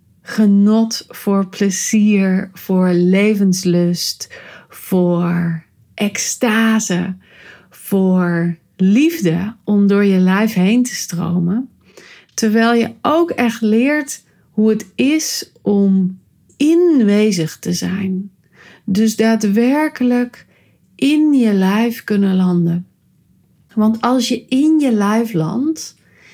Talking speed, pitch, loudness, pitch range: 95 wpm, 205 Hz, -15 LUFS, 185-235 Hz